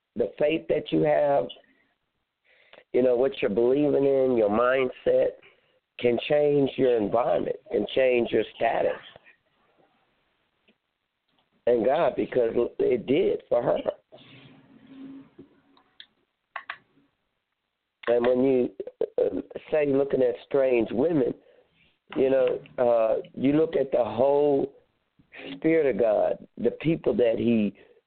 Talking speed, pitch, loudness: 110 wpm, 145 Hz, -25 LUFS